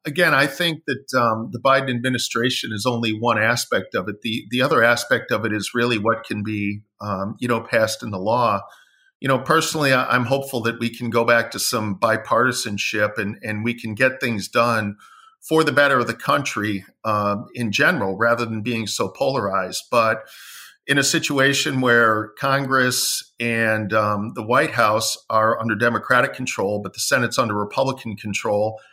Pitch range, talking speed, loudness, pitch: 110-130 Hz, 180 wpm, -20 LUFS, 115 Hz